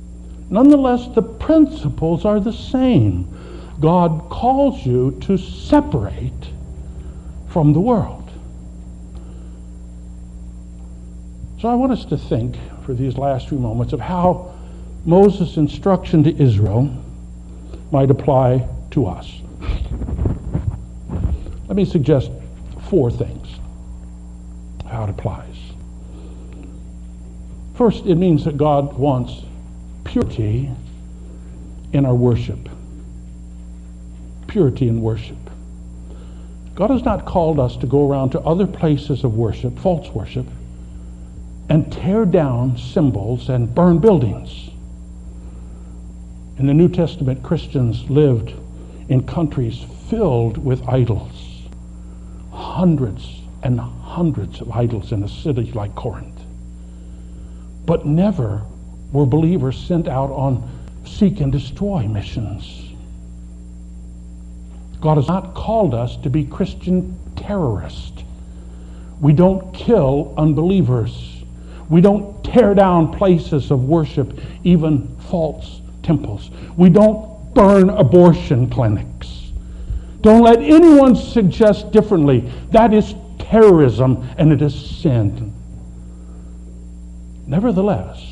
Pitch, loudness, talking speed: 110 Hz, -16 LUFS, 105 wpm